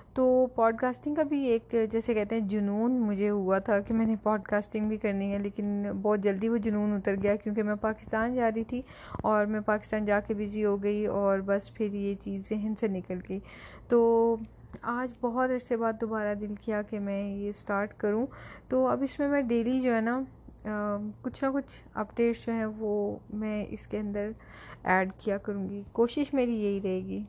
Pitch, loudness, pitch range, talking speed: 215 Hz, -30 LUFS, 205-230 Hz, 205 wpm